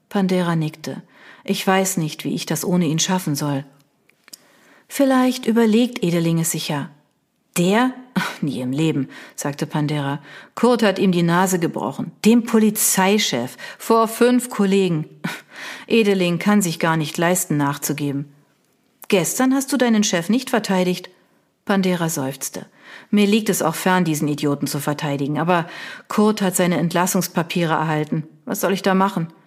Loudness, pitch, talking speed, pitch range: -19 LUFS, 180 Hz, 145 wpm, 155-215 Hz